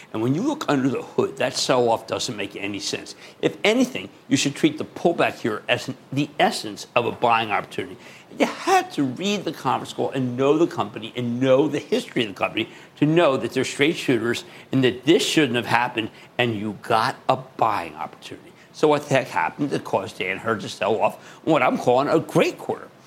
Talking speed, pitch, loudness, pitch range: 215 wpm, 140 Hz, -22 LUFS, 125-170 Hz